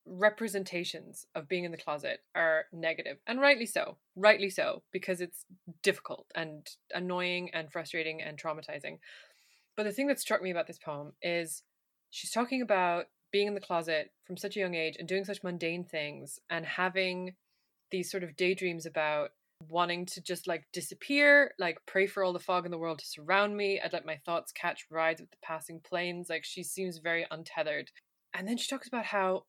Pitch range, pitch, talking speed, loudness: 165-195 Hz, 180 Hz, 190 wpm, -32 LUFS